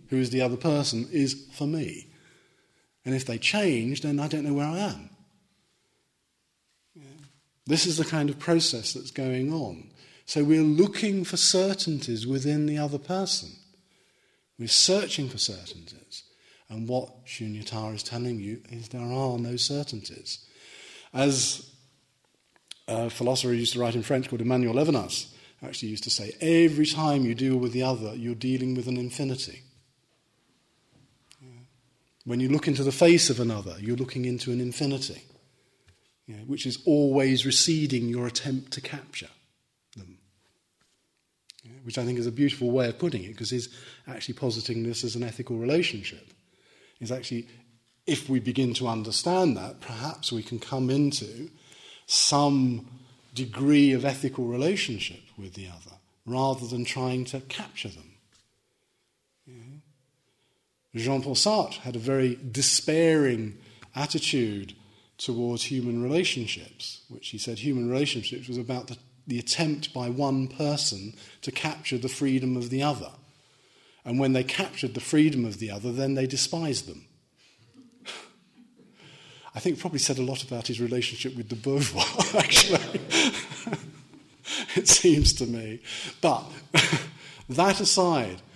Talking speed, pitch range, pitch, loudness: 145 wpm, 120-145 Hz, 130 Hz, -26 LUFS